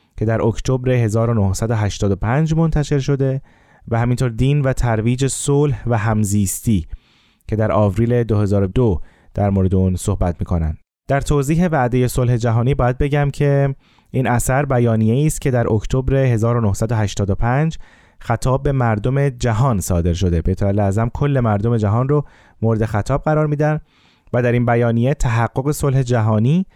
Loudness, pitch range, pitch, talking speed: -18 LUFS, 105-135 Hz, 120 Hz, 140 wpm